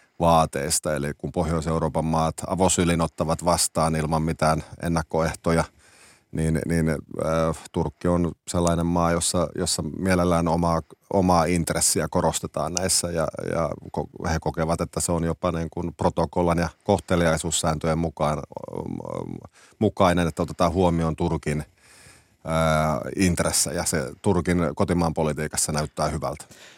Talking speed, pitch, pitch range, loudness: 115 wpm, 85 Hz, 80-90 Hz, -24 LUFS